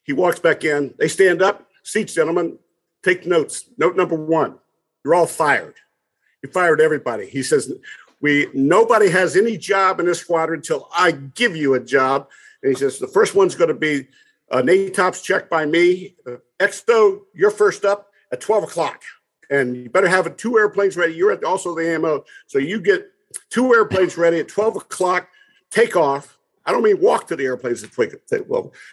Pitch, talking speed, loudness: 190 Hz, 195 wpm, -18 LUFS